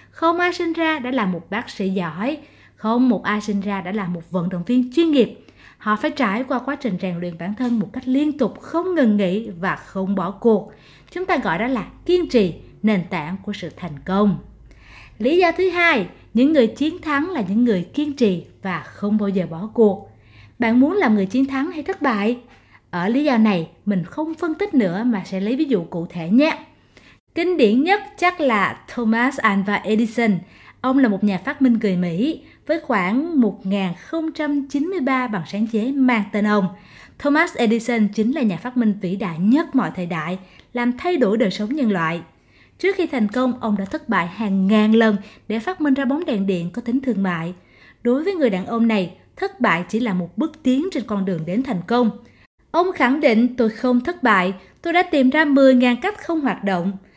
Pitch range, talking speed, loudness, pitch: 195-280 Hz, 215 wpm, -20 LUFS, 230 Hz